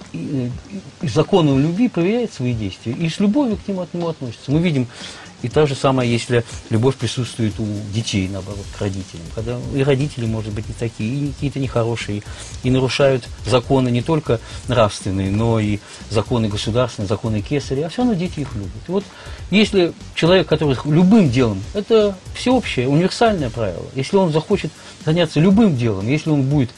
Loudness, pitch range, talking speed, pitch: -19 LUFS, 110-160 Hz, 170 wpm, 130 Hz